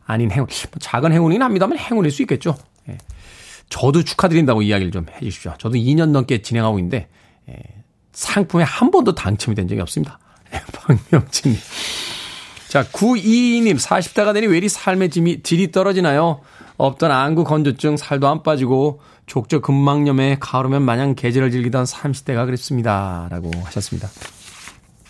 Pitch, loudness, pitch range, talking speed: 135 Hz, -18 LUFS, 115-165 Hz, 325 characters per minute